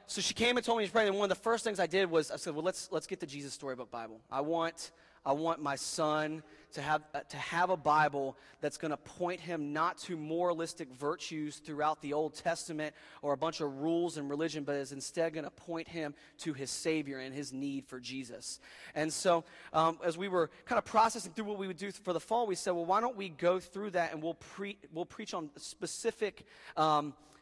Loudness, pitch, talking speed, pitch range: -35 LUFS, 160 Hz, 240 wpm, 150-180 Hz